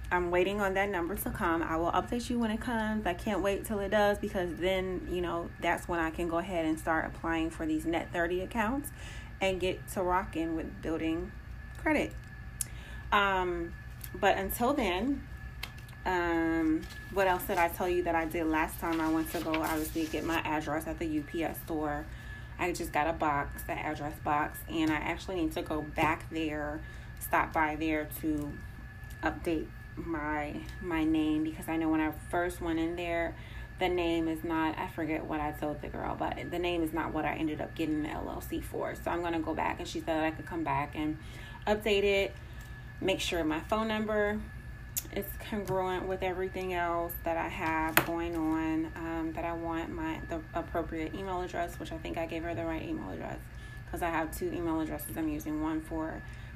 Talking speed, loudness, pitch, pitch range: 200 wpm, -33 LUFS, 165 Hz, 160-180 Hz